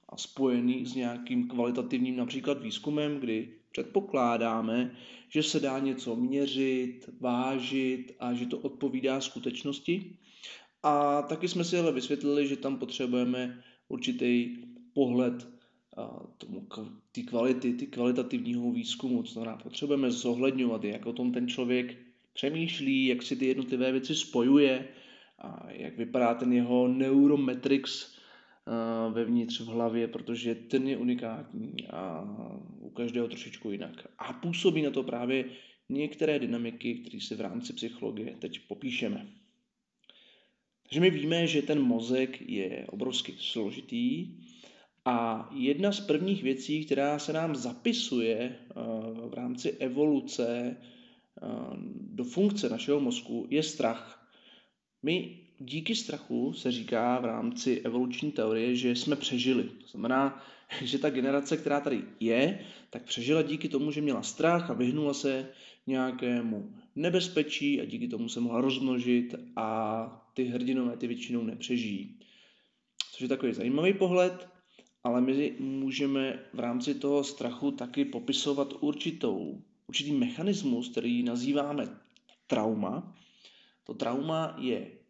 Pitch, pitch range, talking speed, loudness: 135 Hz, 125-170 Hz, 125 wpm, -31 LUFS